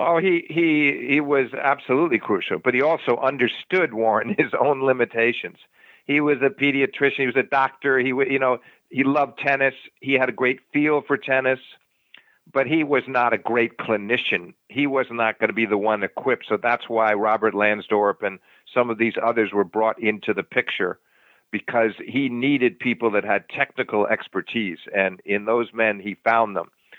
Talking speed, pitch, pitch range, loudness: 185 wpm, 125 Hz, 110-135 Hz, -21 LUFS